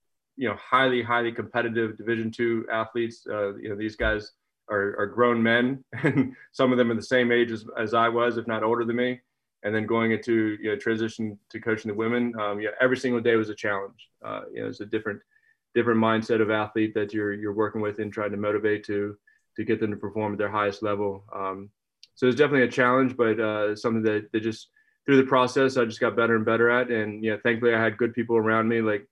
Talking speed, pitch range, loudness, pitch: 240 wpm, 105-120 Hz, -25 LUFS, 115 Hz